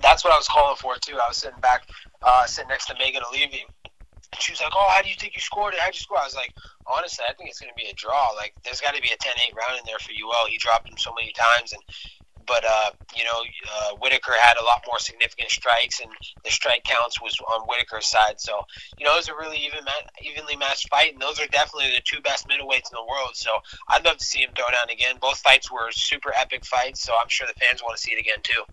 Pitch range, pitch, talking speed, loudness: 110-145 Hz, 120 Hz, 275 wpm, -22 LUFS